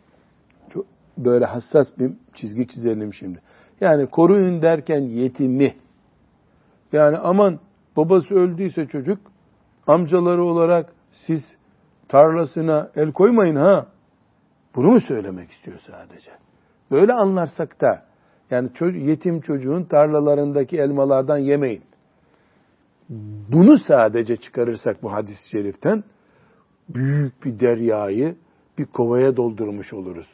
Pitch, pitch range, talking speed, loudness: 145 Hz, 120-170 Hz, 95 wpm, -19 LUFS